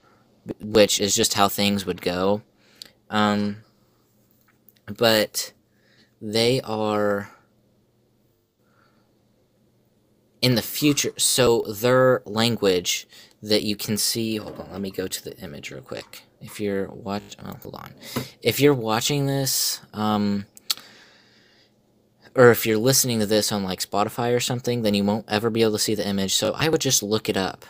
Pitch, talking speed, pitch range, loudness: 110 Hz, 150 wpm, 105-115 Hz, -22 LUFS